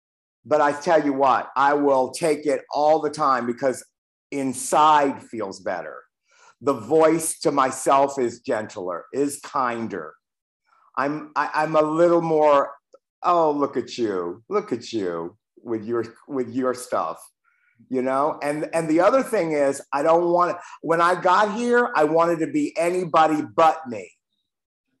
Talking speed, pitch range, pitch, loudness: 155 wpm, 135-165 Hz, 150 Hz, -22 LUFS